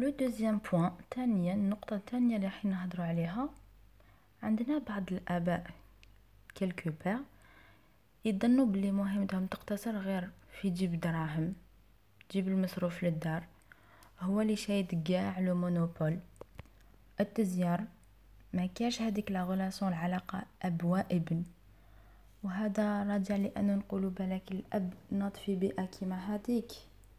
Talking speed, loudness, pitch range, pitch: 115 wpm, -35 LUFS, 170-205 Hz, 190 Hz